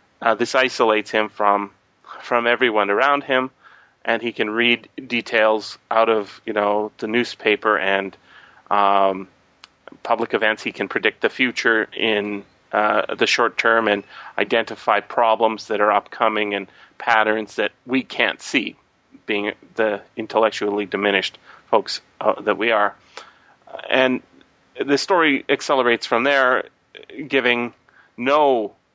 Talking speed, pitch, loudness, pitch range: 130 wpm, 110 Hz, -20 LUFS, 105-120 Hz